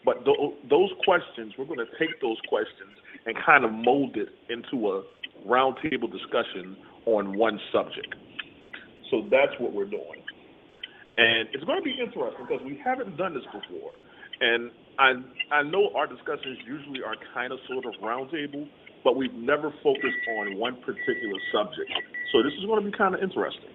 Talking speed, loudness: 170 wpm, -27 LUFS